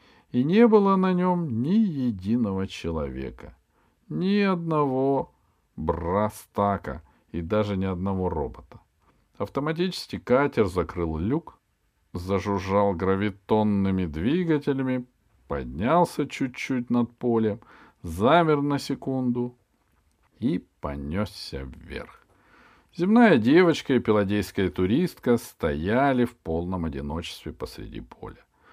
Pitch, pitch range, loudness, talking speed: 105 Hz, 90-140 Hz, -25 LUFS, 90 wpm